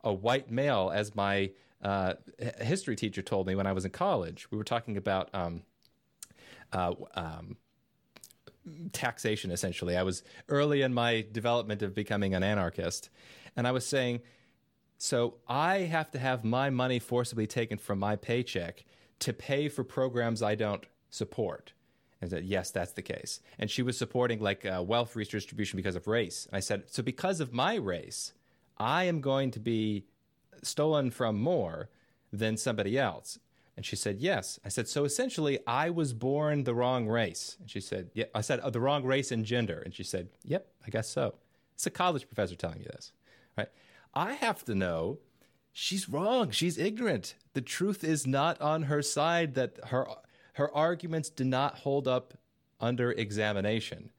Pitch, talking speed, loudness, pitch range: 120 Hz, 175 wpm, -32 LUFS, 105-140 Hz